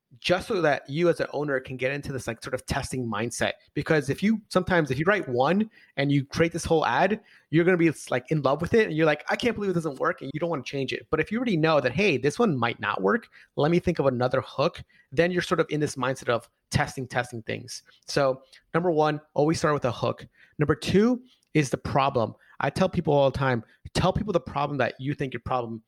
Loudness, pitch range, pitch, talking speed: -26 LUFS, 130-175 Hz, 150 Hz, 255 wpm